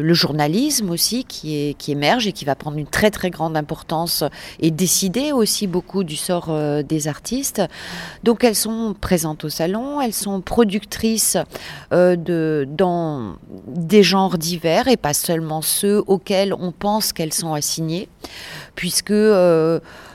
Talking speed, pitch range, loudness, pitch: 155 wpm, 155-205 Hz, -19 LUFS, 180 Hz